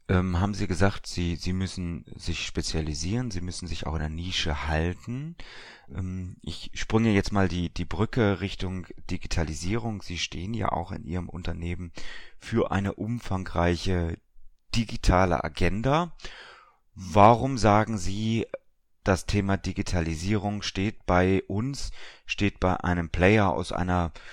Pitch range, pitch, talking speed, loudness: 85-105 Hz, 95 Hz, 130 wpm, -27 LUFS